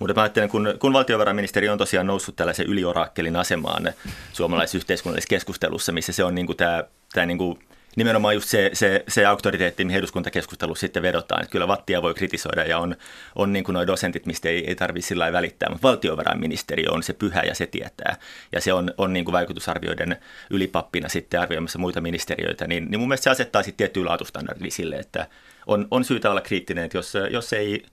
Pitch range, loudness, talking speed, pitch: 85-100 Hz, -23 LUFS, 185 wpm, 90 Hz